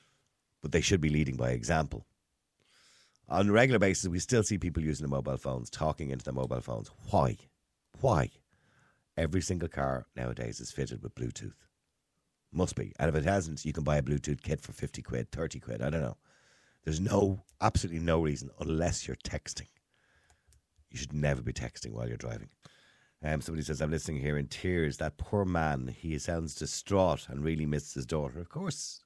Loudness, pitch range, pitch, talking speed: -33 LUFS, 70-85 Hz, 75 Hz, 190 wpm